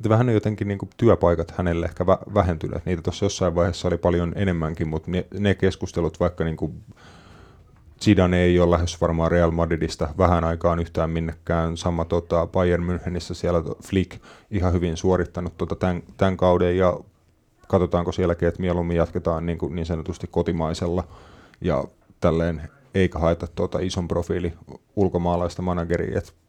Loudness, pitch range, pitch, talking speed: -23 LUFS, 85-95 Hz, 90 Hz, 150 wpm